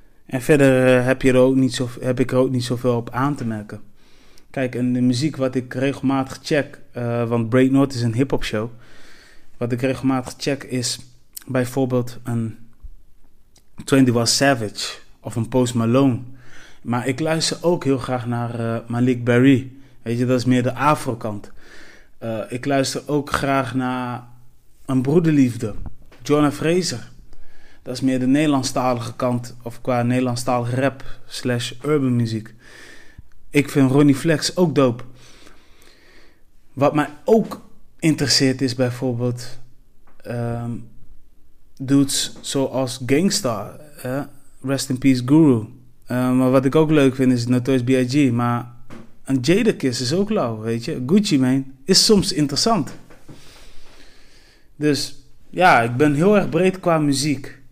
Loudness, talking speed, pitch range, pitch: -19 LUFS, 145 wpm, 120-140 Hz, 130 Hz